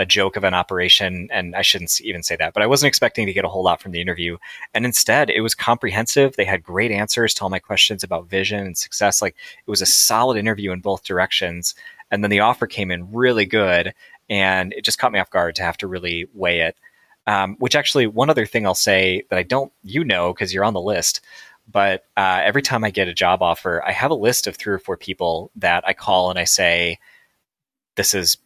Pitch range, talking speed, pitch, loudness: 90-115 Hz, 240 wpm, 100 Hz, -18 LUFS